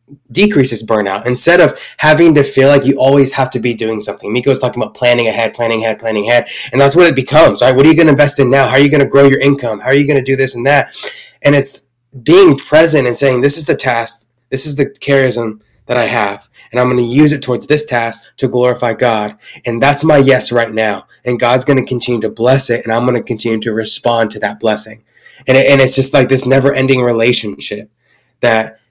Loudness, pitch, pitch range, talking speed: -11 LUFS, 125 Hz, 115-140 Hz, 250 wpm